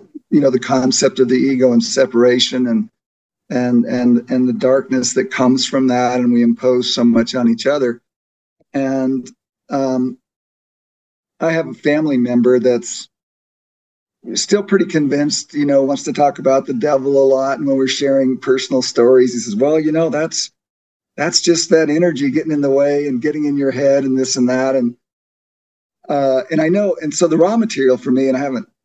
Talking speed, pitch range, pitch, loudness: 190 wpm, 125-145 Hz, 135 Hz, -15 LUFS